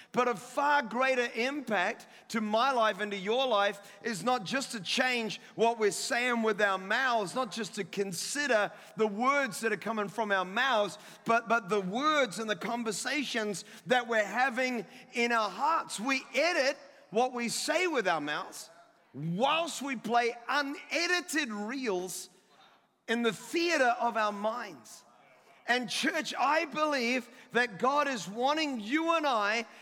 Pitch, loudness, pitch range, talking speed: 235 Hz, -30 LUFS, 210-270 Hz, 155 wpm